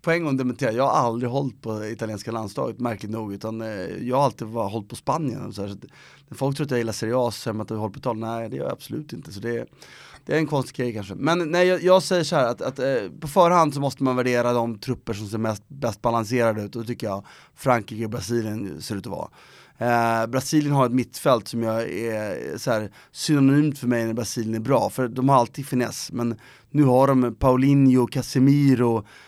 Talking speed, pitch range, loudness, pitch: 210 wpm, 115-135 Hz, -23 LUFS, 120 Hz